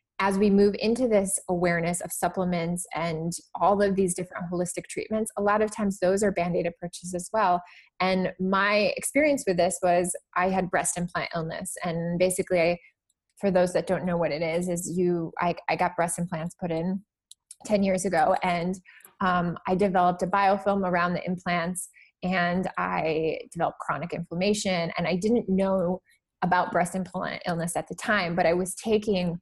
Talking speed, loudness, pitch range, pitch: 180 wpm, -26 LUFS, 175-195 Hz, 180 Hz